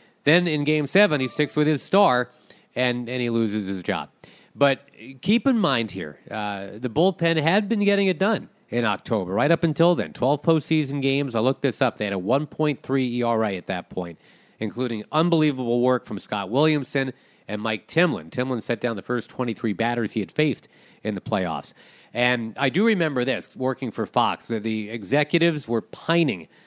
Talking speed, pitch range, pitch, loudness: 190 wpm, 115-155 Hz, 130 Hz, -23 LUFS